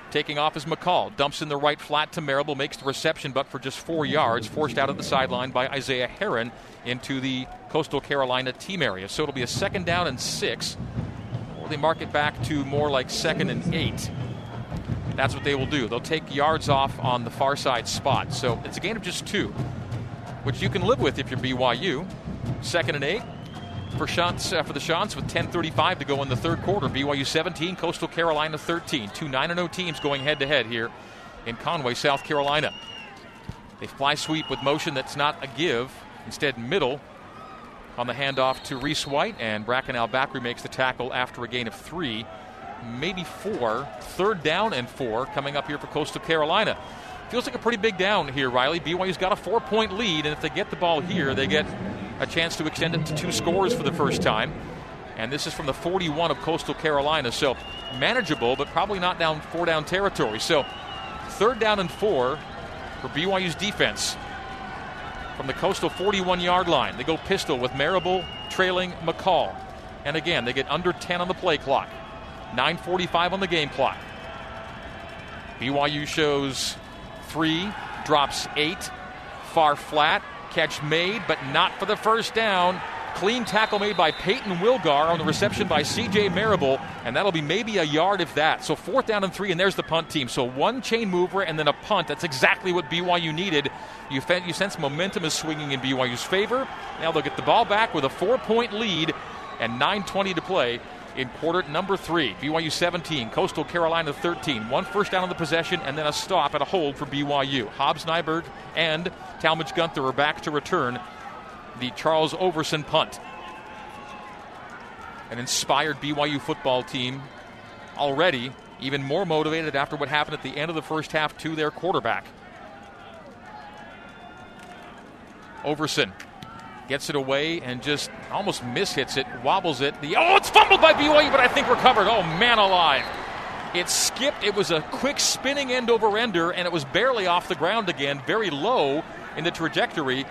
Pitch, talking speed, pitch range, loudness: 155 Hz, 185 wpm, 135-180 Hz, -24 LUFS